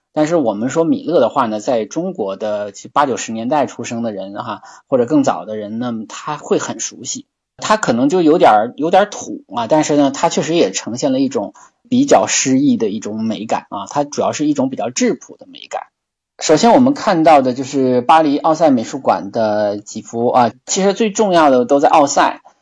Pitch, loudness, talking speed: 150 Hz, -15 LUFS, 305 characters per minute